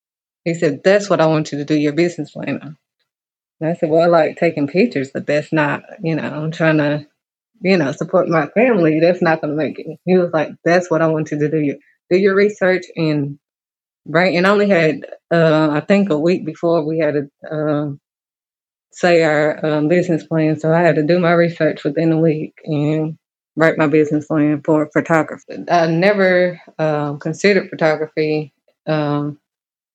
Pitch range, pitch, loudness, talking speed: 150-170 Hz, 160 Hz, -16 LUFS, 190 wpm